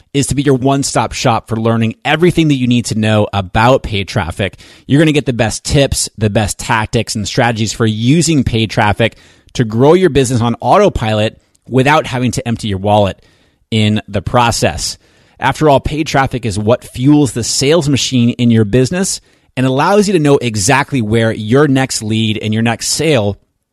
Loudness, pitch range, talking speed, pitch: -13 LUFS, 110-140 Hz, 190 wpm, 120 Hz